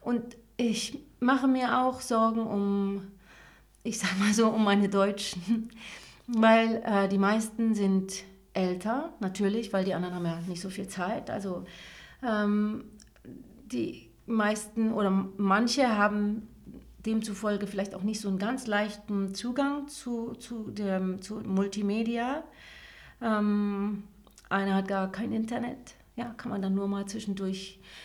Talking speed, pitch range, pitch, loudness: 135 wpm, 195-230 Hz, 210 Hz, -29 LUFS